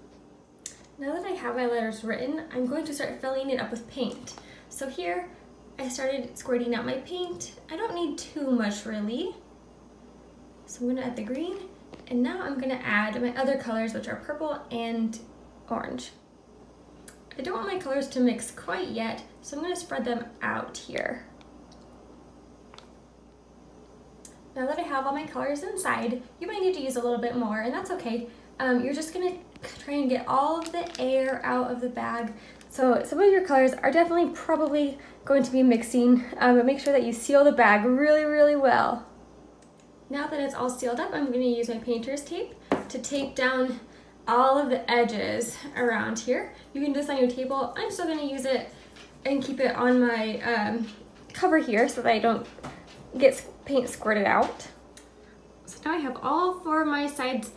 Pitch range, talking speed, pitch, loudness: 235-290 Hz, 195 wpm, 260 Hz, -27 LUFS